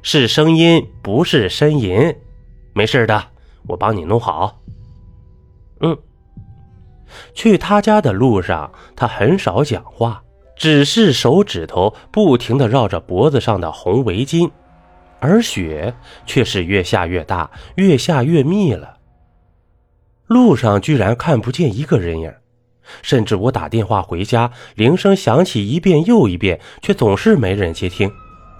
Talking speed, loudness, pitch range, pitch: 195 characters per minute, -15 LUFS, 95-150 Hz, 115 Hz